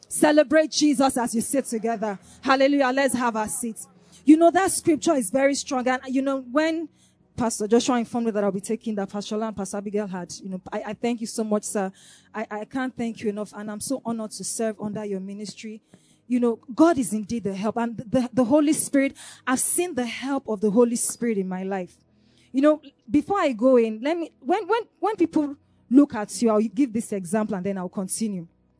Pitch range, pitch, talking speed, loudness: 210-270 Hz, 230 Hz, 220 wpm, -24 LUFS